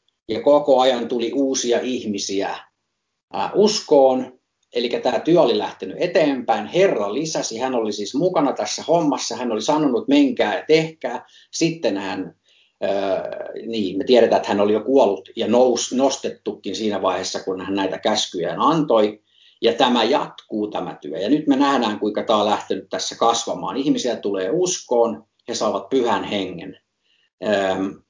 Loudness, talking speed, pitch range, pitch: -20 LUFS, 145 wpm, 105-140 Hz, 125 Hz